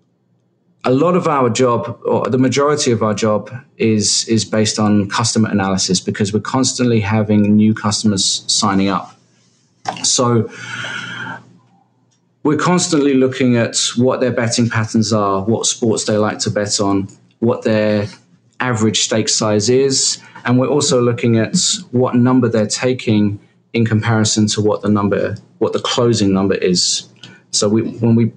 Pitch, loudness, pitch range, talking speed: 110 Hz, -15 LUFS, 105-125 Hz, 150 wpm